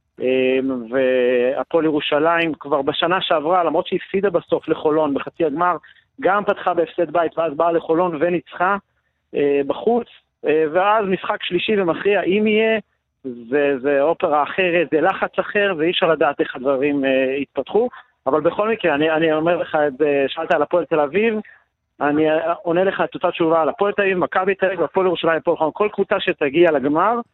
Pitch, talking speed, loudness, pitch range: 170 Hz, 160 wpm, -19 LUFS, 150-190 Hz